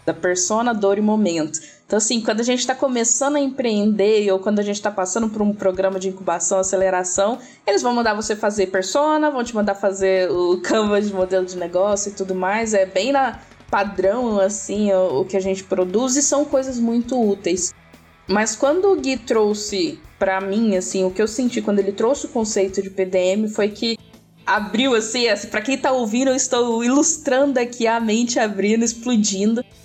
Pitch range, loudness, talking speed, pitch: 190-240 Hz, -19 LUFS, 195 wpm, 210 Hz